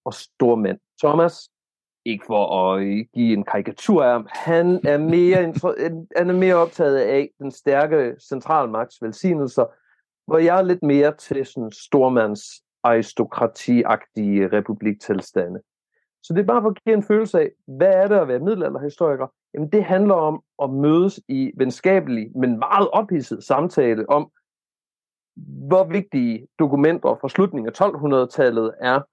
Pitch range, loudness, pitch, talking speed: 120-180 Hz, -20 LUFS, 145 Hz, 140 wpm